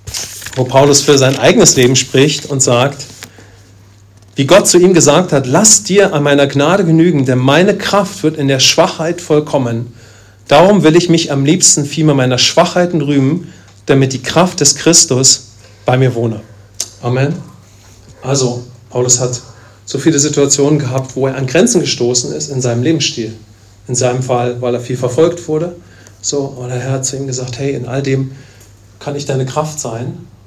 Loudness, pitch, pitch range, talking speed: -11 LUFS, 135 Hz, 120-150 Hz, 175 wpm